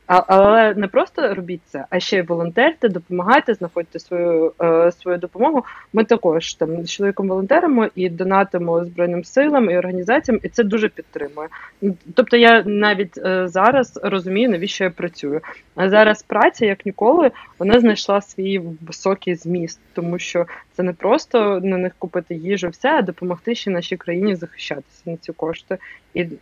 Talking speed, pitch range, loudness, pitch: 160 wpm, 175-210 Hz, -18 LUFS, 185 Hz